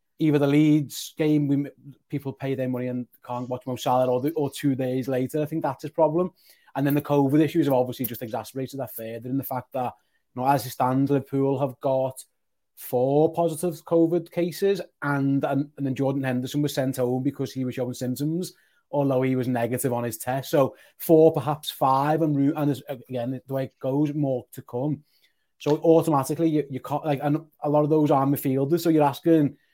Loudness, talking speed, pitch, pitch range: -25 LUFS, 210 wpm, 140 Hz, 130-150 Hz